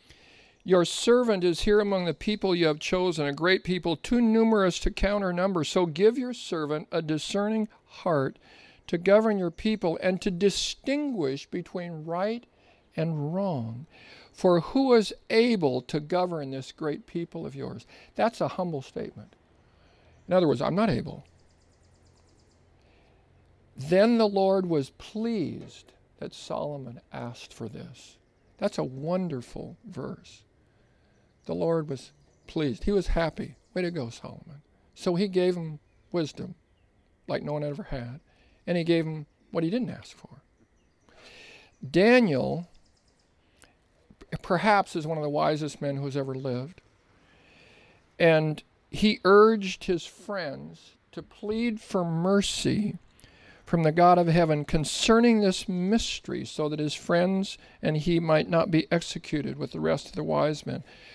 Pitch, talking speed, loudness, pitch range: 170 Hz, 145 wpm, -26 LUFS, 145-195 Hz